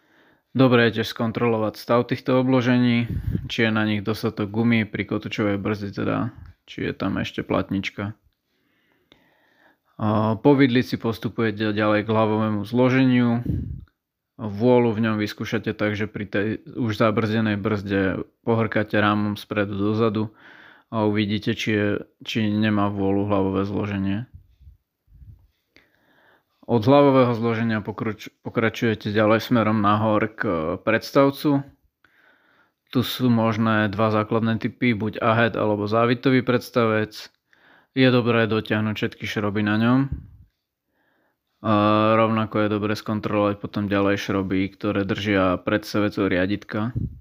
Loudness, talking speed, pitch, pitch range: -22 LUFS, 115 wpm, 110 Hz, 105-115 Hz